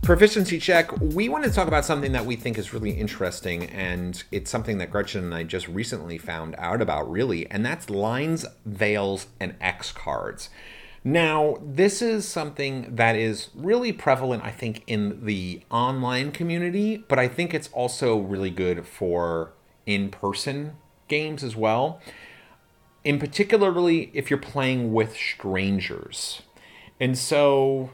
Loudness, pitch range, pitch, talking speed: -25 LUFS, 100-150 Hz, 125 Hz, 150 wpm